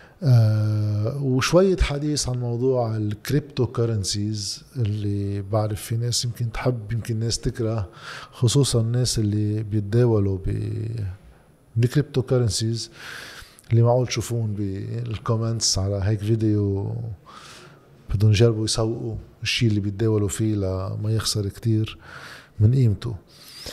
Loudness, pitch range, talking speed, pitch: -23 LUFS, 105-120 Hz, 105 wpm, 110 Hz